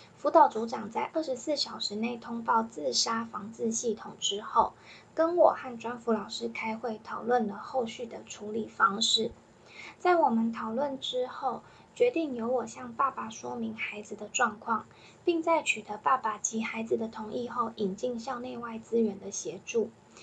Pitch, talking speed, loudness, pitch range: 230 Hz, 250 characters per minute, -30 LUFS, 220-260 Hz